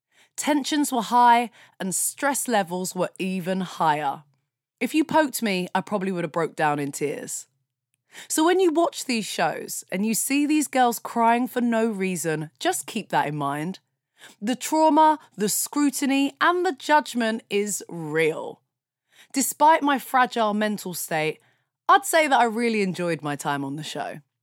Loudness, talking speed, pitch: -23 LUFS, 160 wpm, 215 Hz